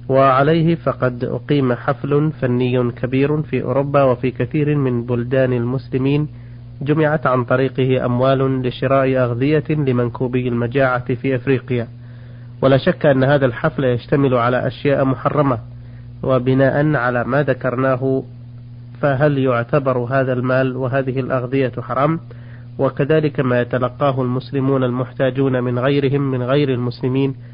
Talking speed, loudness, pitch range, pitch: 115 wpm, -18 LUFS, 125-140 Hz, 130 Hz